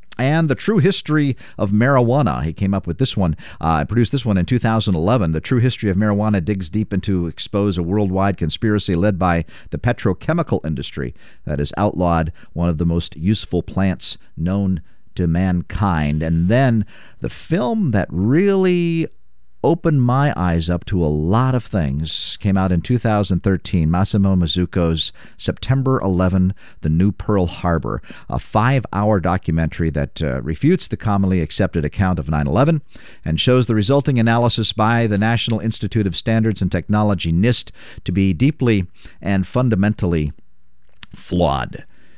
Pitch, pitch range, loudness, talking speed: 100 Hz, 85-115 Hz, -19 LUFS, 155 wpm